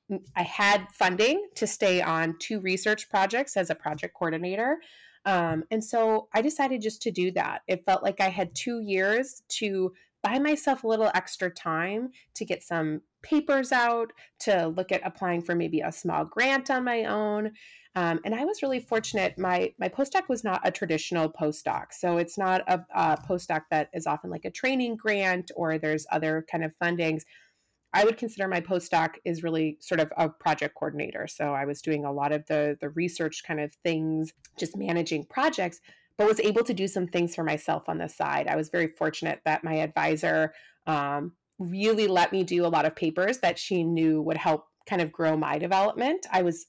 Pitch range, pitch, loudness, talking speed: 160-215 Hz, 180 Hz, -27 LUFS, 200 wpm